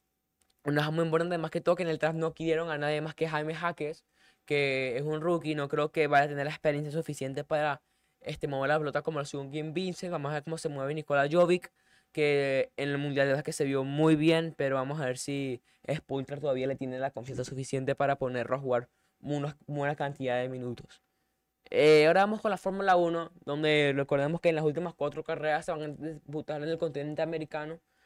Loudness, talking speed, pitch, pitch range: -30 LUFS, 220 wpm, 150 Hz, 140-160 Hz